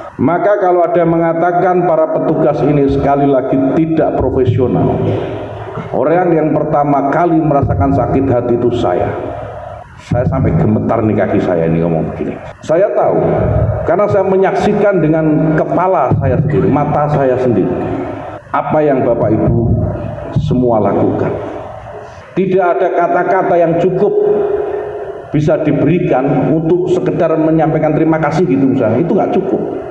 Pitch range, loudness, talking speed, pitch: 130-175 Hz, -13 LUFS, 130 wpm, 155 Hz